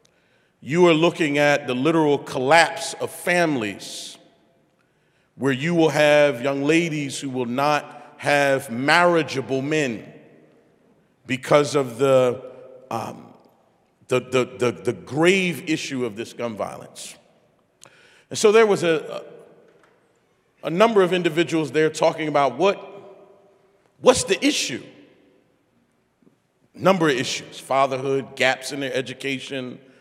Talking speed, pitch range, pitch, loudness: 120 wpm, 130-175 Hz, 145 Hz, -21 LUFS